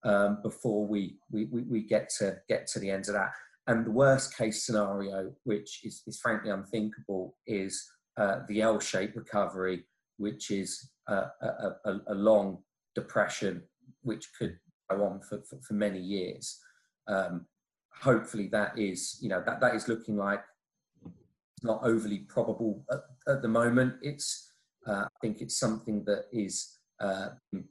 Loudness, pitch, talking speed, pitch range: -32 LUFS, 105 Hz, 160 wpm, 100-115 Hz